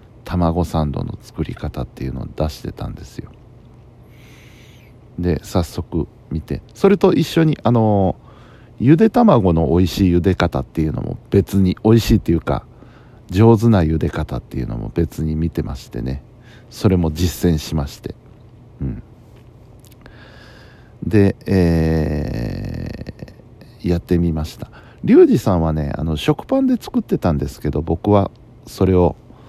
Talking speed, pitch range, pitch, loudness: 270 characters per minute, 80-120 Hz, 105 Hz, -18 LUFS